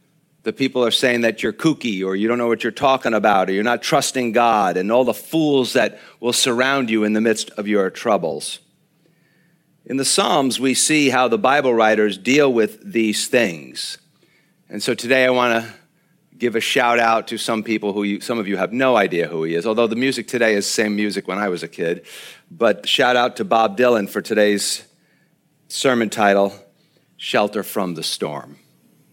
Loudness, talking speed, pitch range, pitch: -18 LUFS, 200 wpm, 105-135 Hz, 120 Hz